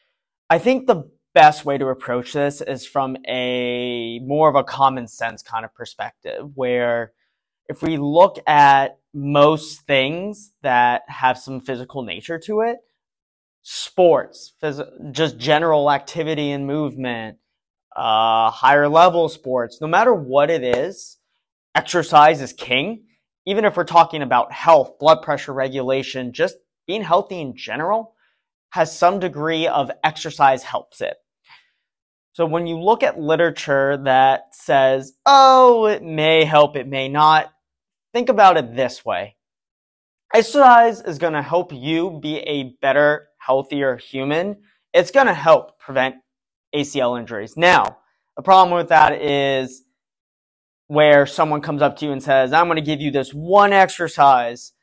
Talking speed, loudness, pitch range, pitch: 145 wpm, -17 LUFS, 130-170 Hz, 145 Hz